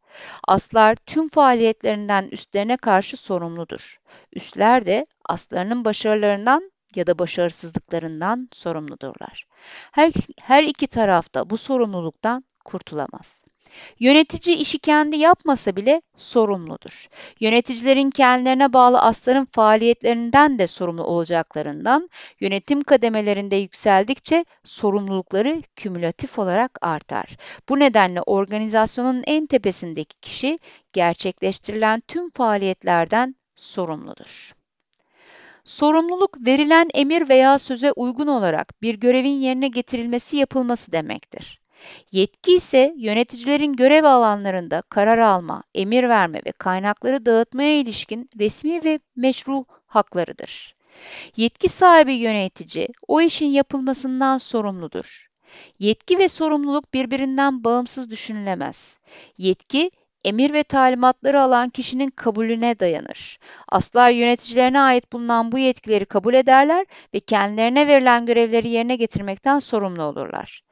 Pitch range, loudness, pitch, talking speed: 205-275 Hz, -19 LUFS, 240 Hz, 100 wpm